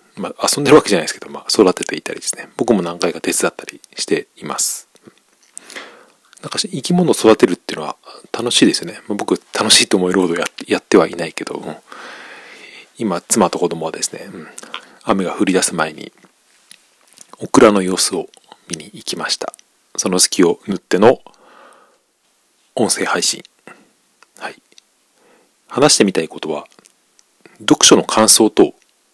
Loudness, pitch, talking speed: -15 LUFS, 110 Hz, 315 characters per minute